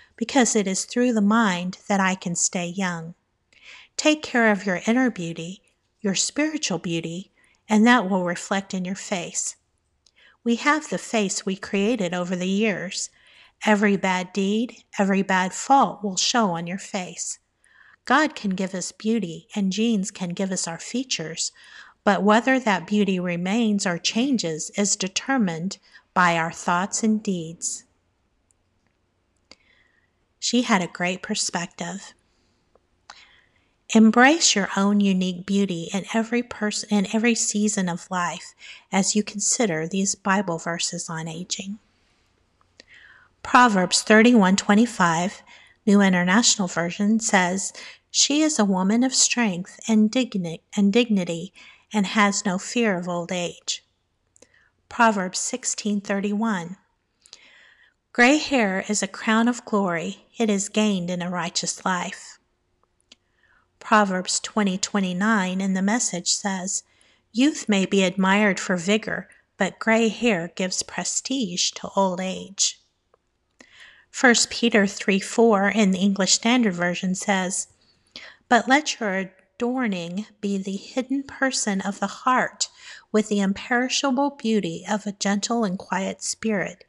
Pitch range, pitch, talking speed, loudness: 185-225 Hz, 200 Hz, 135 wpm, -22 LUFS